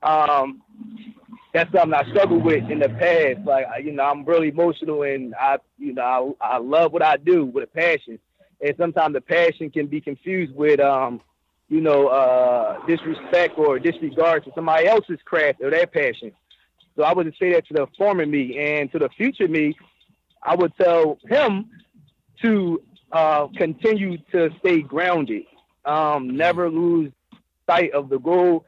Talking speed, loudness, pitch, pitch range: 170 wpm, -20 LUFS, 165 Hz, 145-185 Hz